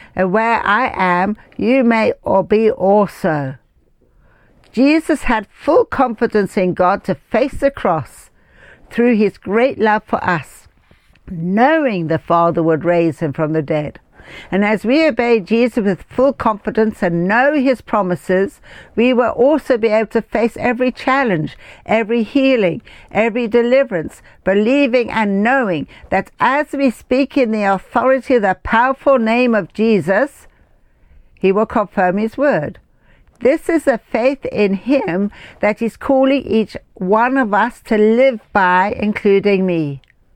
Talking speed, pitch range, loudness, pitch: 145 wpm, 190-255 Hz, -15 LUFS, 220 Hz